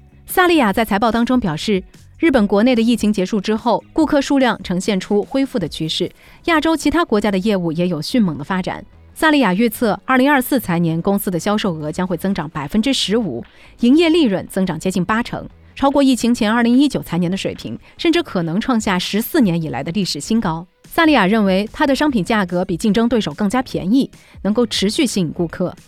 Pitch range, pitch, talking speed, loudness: 180-255 Hz, 210 Hz, 330 characters per minute, -17 LUFS